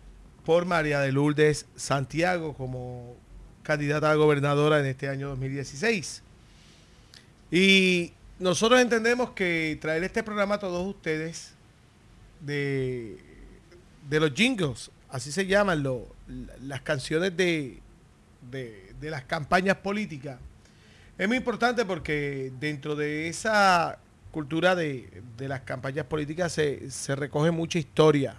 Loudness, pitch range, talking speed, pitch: -26 LUFS, 135-180 Hz, 120 wpm, 150 Hz